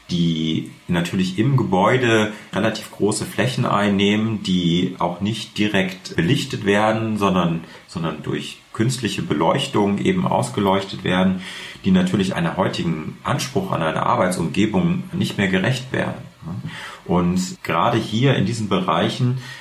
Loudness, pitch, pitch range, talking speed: -20 LUFS, 105 Hz, 95-125 Hz, 120 wpm